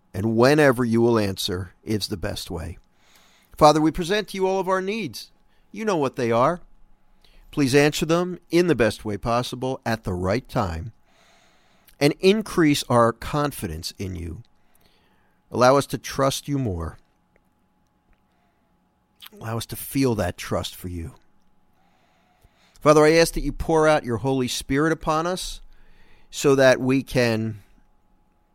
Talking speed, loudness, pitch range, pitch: 150 wpm, -22 LUFS, 105-150 Hz, 125 Hz